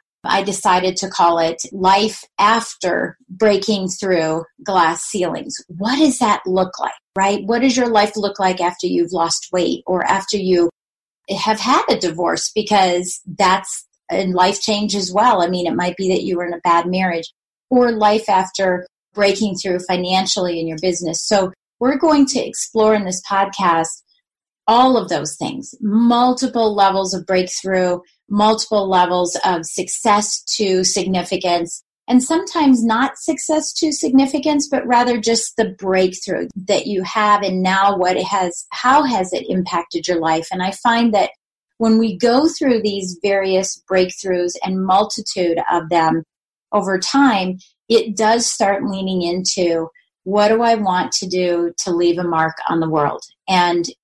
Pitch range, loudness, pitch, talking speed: 180-220 Hz, -17 LUFS, 190 Hz, 160 wpm